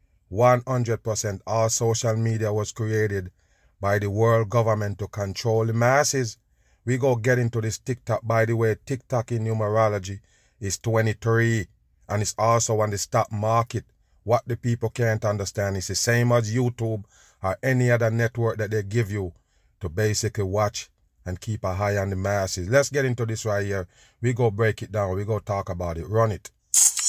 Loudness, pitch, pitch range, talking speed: -24 LUFS, 110 Hz, 100-115 Hz, 180 wpm